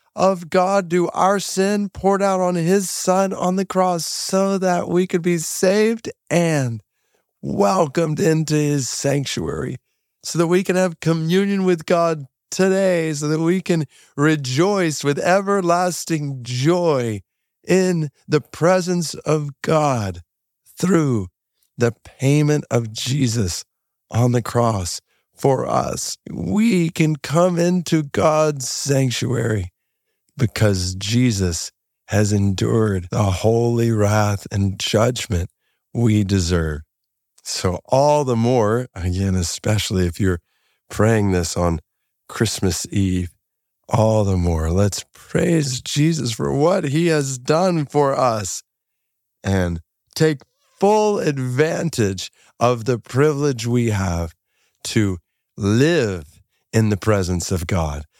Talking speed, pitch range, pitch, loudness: 120 wpm, 105-170 Hz, 135 Hz, -19 LUFS